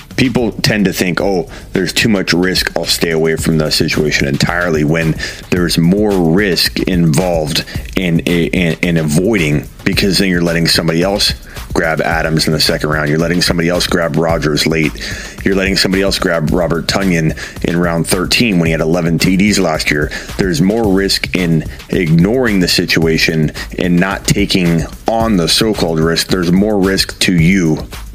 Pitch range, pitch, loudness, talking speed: 80-95 Hz, 85 Hz, -13 LUFS, 170 wpm